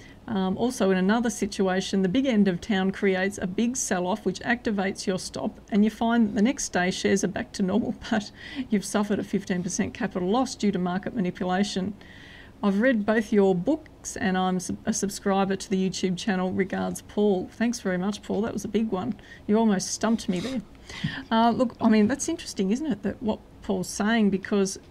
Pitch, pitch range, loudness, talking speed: 205 Hz, 190-225 Hz, -26 LUFS, 200 wpm